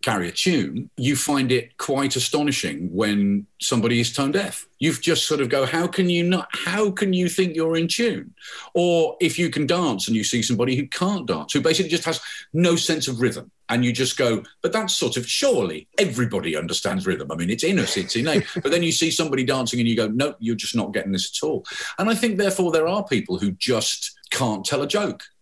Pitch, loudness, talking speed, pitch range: 150 Hz, -22 LUFS, 235 wpm, 120-175 Hz